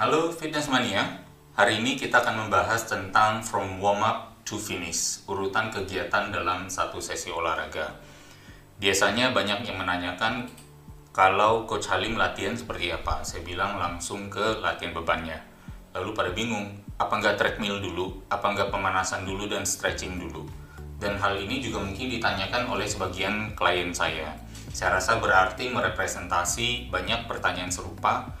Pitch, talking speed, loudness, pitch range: 100 Hz, 140 wpm, -26 LUFS, 90-110 Hz